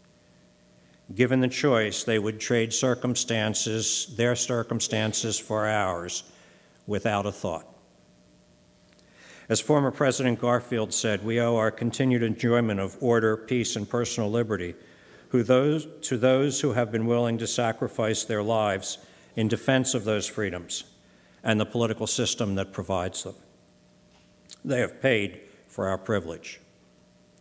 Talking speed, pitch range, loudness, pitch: 125 wpm, 85-120 Hz, -26 LUFS, 110 Hz